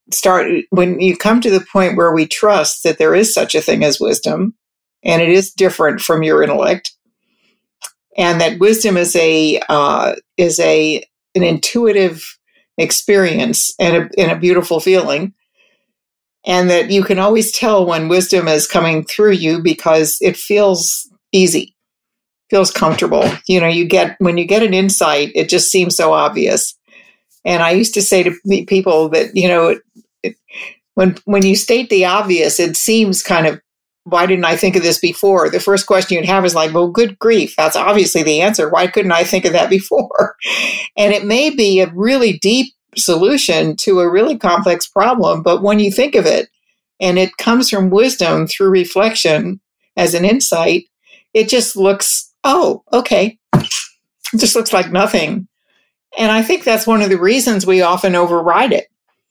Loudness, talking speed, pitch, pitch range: -13 LUFS, 175 wpm, 190 Hz, 175-215 Hz